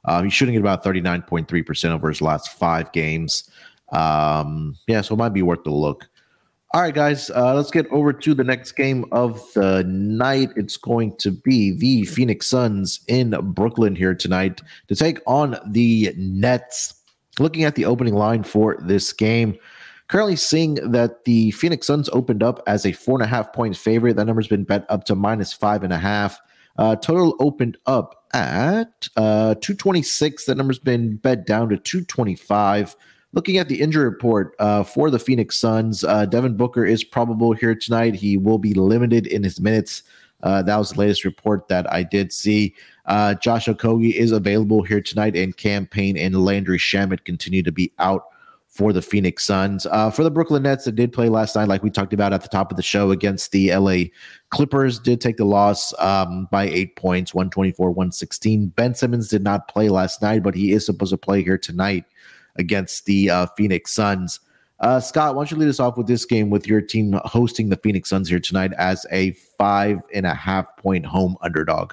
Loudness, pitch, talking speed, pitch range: -20 LUFS, 105 Hz, 200 wpm, 95-120 Hz